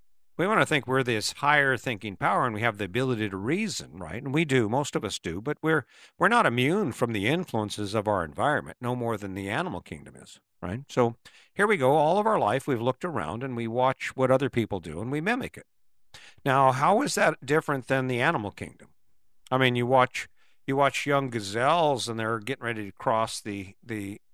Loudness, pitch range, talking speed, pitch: -26 LUFS, 110-140 Hz, 220 wpm, 125 Hz